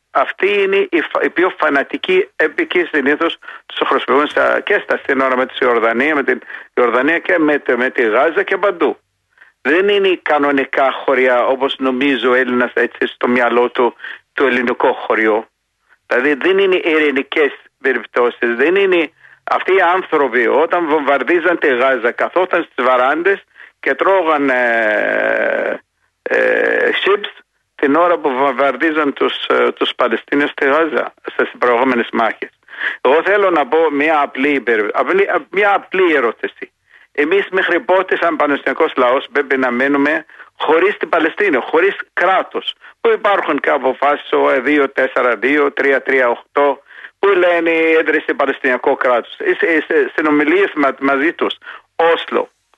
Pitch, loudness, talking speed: 170 Hz, -14 LUFS, 140 wpm